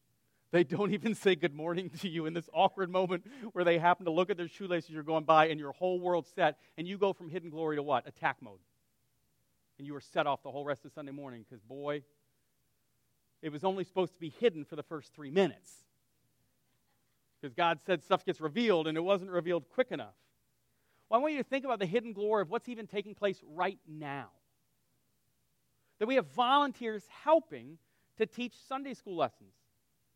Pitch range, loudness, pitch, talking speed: 150-200 Hz, -33 LUFS, 175 Hz, 205 wpm